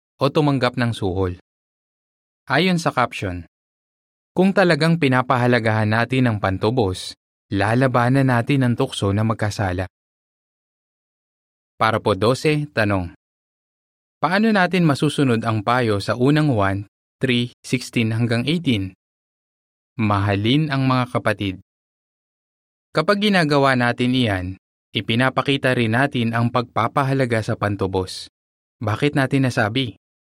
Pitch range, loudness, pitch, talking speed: 100-135 Hz, -20 LUFS, 120 Hz, 105 wpm